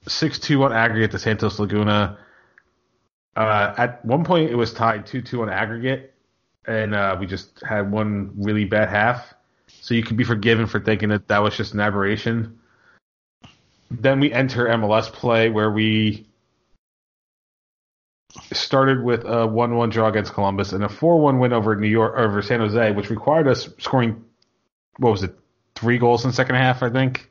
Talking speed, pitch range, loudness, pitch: 170 wpm, 105-120 Hz, -20 LUFS, 115 Hz